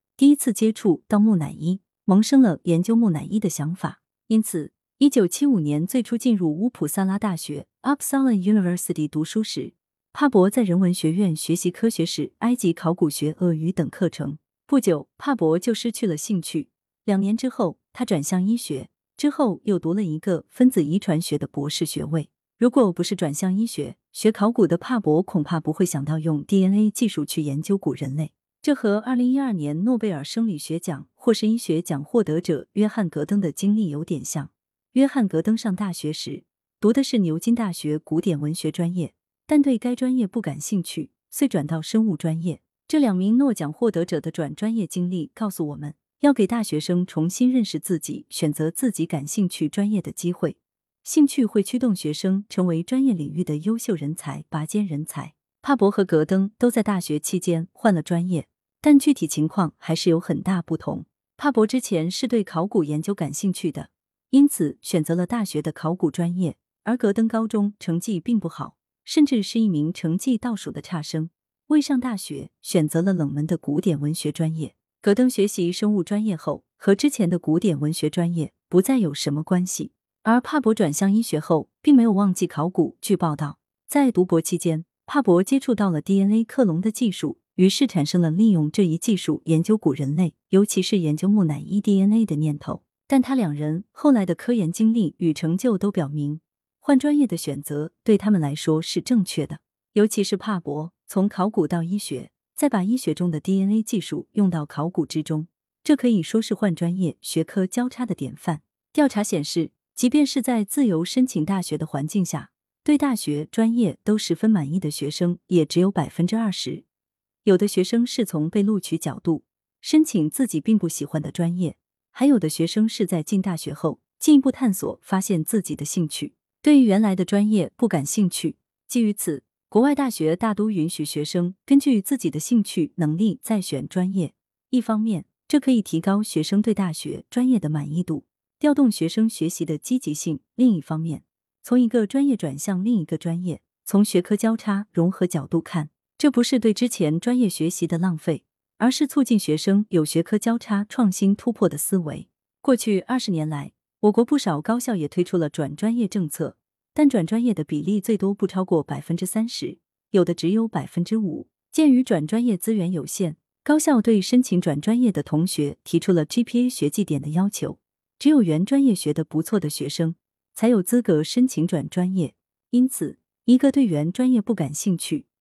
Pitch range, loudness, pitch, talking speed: 160-225 Hz, -22 LUFS, 185 Hz, 295 characters per minute